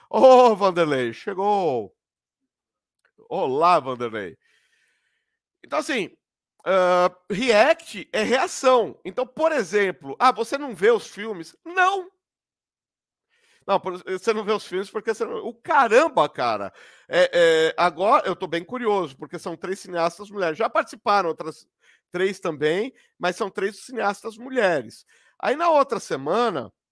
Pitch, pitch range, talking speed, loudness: 205 Hz, 180-260 Hz, 135 wpm, -22 LUFS